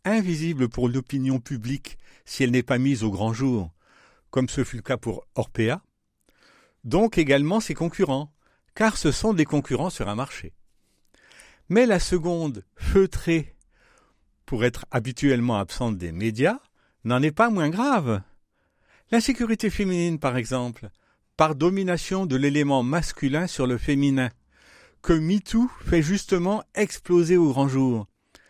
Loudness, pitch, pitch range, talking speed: -24 LUFS, 140 Hz, 125-175 Hz, 140 wpm